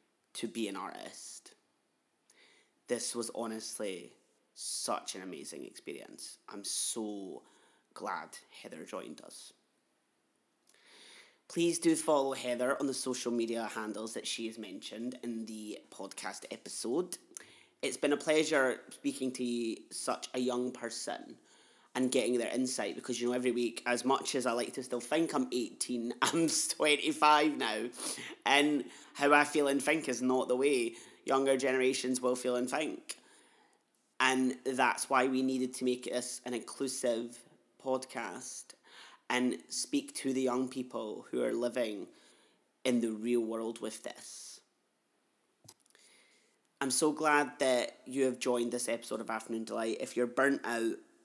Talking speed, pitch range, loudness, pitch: 145 wpm, 120-140 Hz, -33 LUFS, 125 Hz